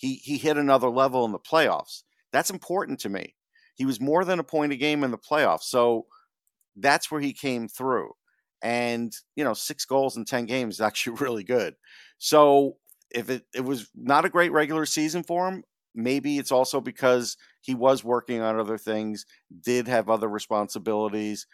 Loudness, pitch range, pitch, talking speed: -25 LUFS, 115-150 Hz, 130 Hz, 185 wpm